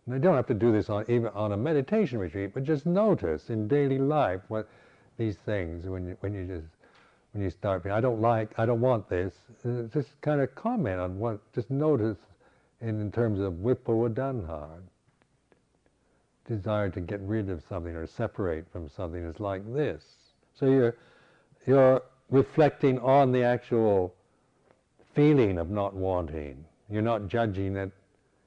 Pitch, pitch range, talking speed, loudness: 110 Hz, 95-130 Hz, 170 wpm, -28 LUFS